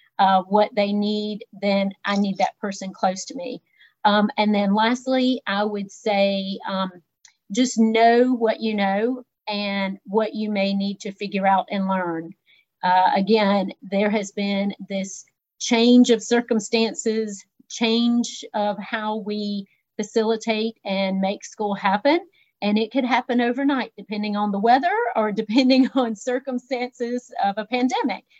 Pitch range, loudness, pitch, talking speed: 200-235 Hz, -22 LUFS, 210 Hz, 145 wpm